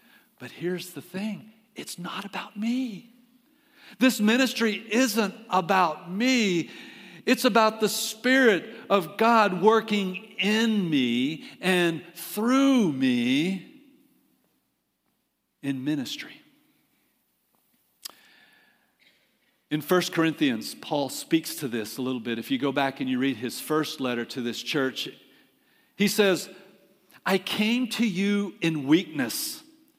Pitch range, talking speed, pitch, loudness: 170-250 Hz, 115 wpm, 205 Hz, -25 LUFS